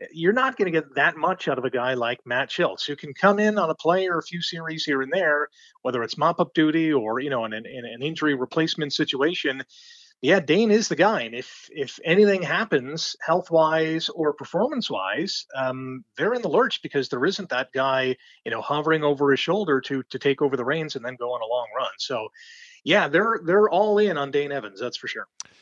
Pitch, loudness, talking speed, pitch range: 155 Hz, -23 LUFS, 220 wpm, 135-190 Hz